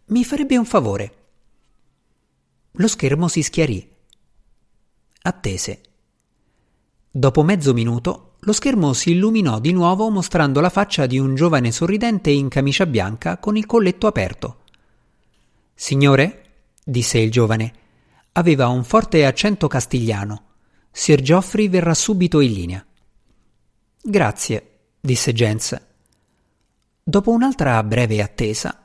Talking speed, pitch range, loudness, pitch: 110 wpm, 115-185 Hz, -18 LUFS, 140 Hz